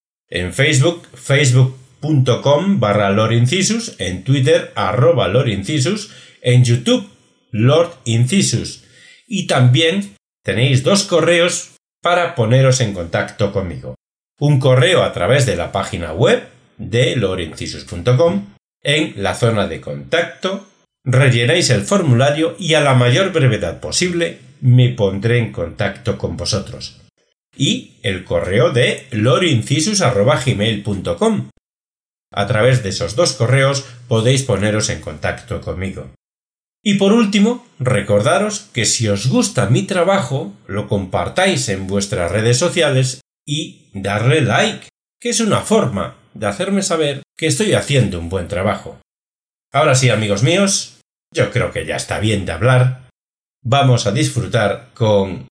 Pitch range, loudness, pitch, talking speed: 105-165 Hz, -16 LUFS, 125 Hz, 125 wpm